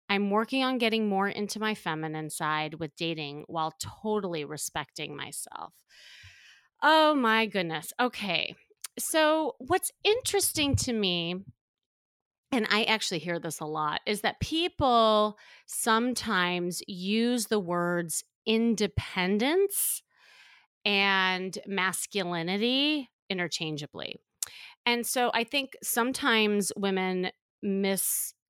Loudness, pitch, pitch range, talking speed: -28 LUFS, 200 Hz, 170-235 Hz, 105 wpm